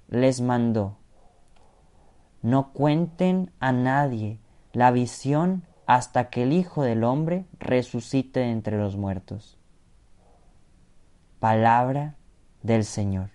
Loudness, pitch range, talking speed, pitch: -24 LUFS, 100-130 Hz, 100 wpm, 120 Hz